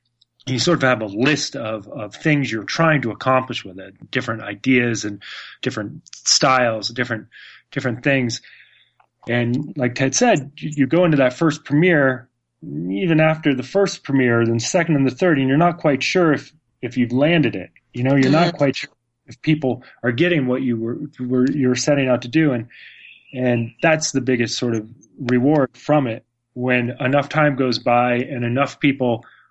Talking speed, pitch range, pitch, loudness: 185 wpm, 120-150 Hz, 130 Hz, -19 LUFS